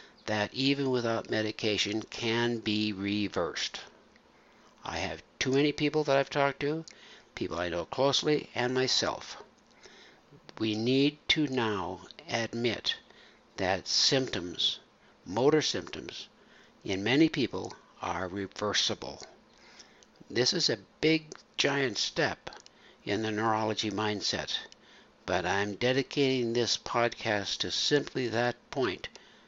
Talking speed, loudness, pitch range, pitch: 110 wpm, -30 LUFS, 105-135 Hz, 120 Hz